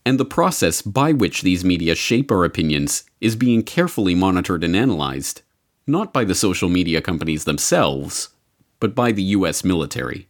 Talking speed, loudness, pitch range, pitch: 165 wpm, -19 LUFS, 80-110 Hz, 90 Hz